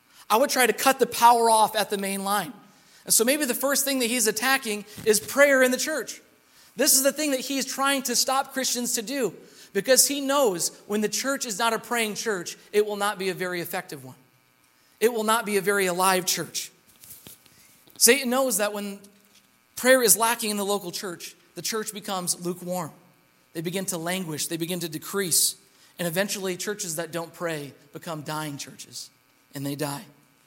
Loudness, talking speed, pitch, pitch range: -24 LUFS, 195 wpm, 205 Hz, 175-240 Hz